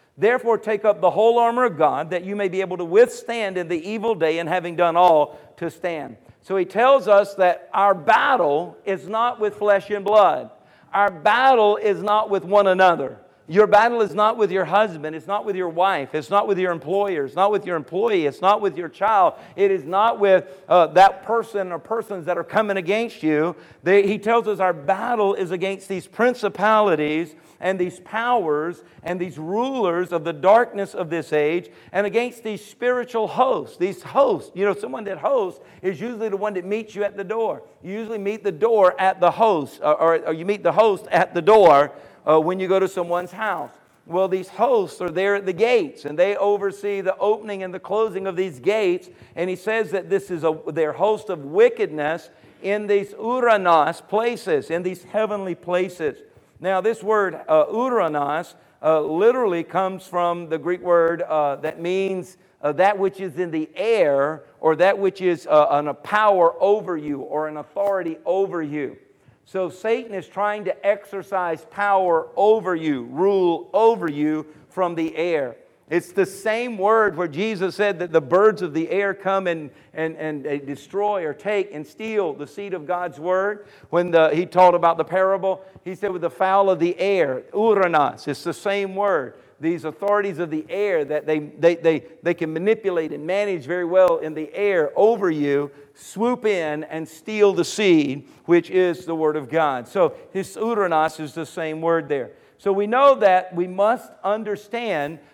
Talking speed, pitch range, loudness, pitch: 190 wpm, 165-210 Hz, -21 LUFS, 190 Hz